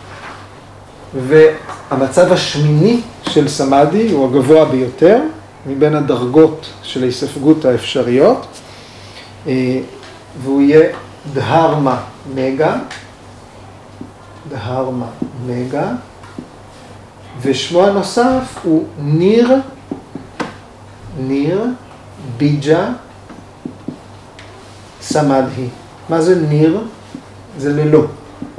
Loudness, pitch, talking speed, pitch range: -14 LUFS, 135 Hz, 65 wpm, 120-155 Hz